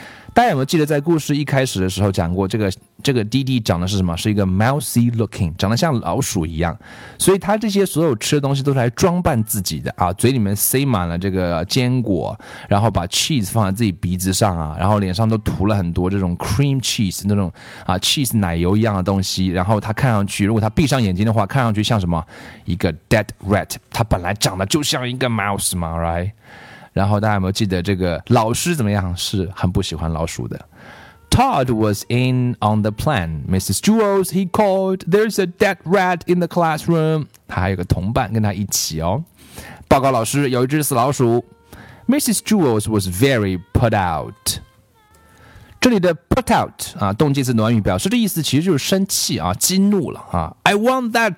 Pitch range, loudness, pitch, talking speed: 95-140 Hz, -18 LUFS, 110 Hz, 415 characters per minute